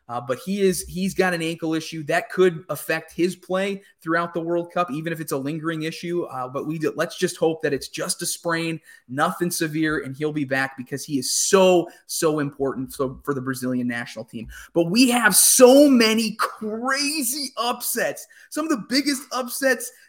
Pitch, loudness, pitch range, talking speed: 170 Hz, -22 LUFS, 150-205 Hz, 195 wpm